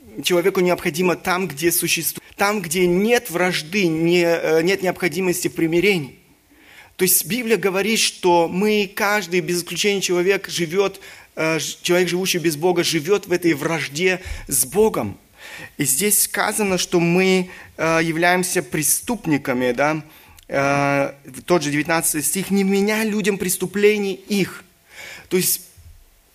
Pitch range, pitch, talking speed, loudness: 165-195 Hz, 180 Hz, 120 wpm, -19 LUFS